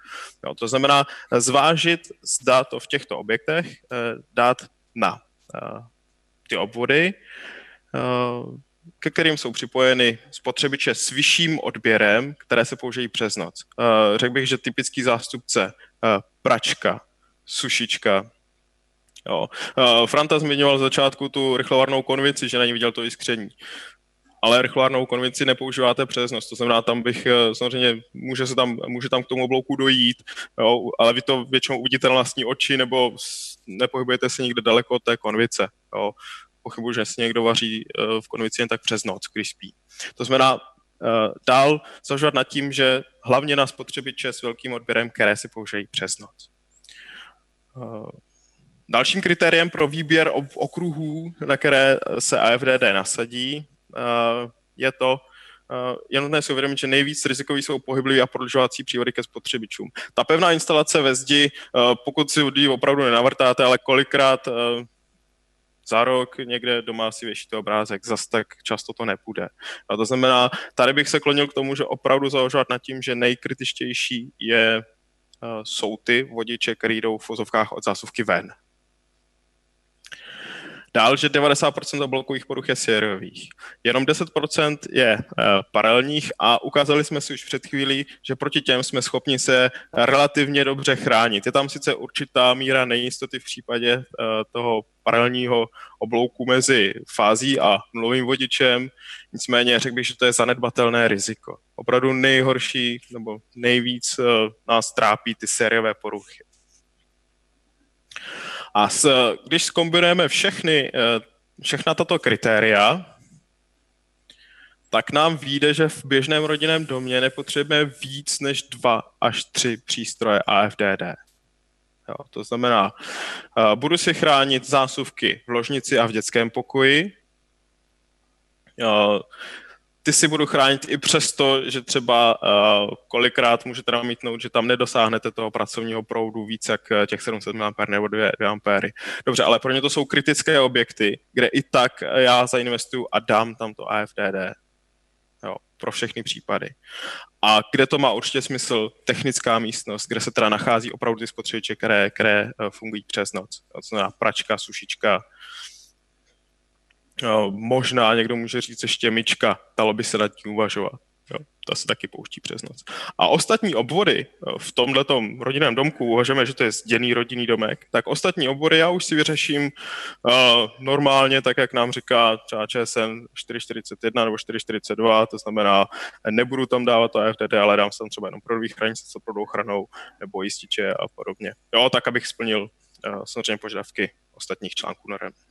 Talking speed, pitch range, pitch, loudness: 145 wpm, 110-135 Hz, 125 Hz, -20 LUFS